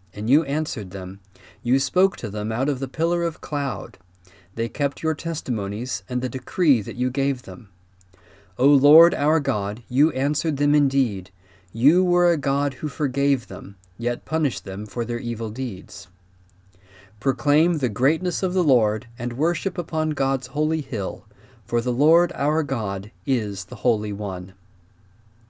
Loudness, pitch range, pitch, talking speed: -23 LUFS, 100-145 Hz, 125 Hz, 160 wpm